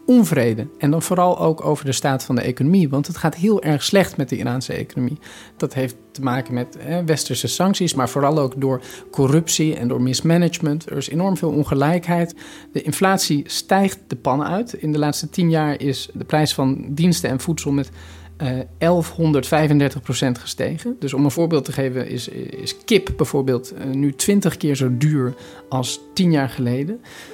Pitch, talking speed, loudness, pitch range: 150 Hz, 185 wpm, -20 LUFS, 130-170 Hz